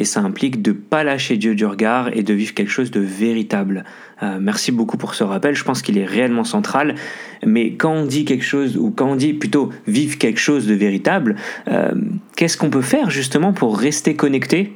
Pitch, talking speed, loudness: 145 Hz, 220 wpm, -18 LUFS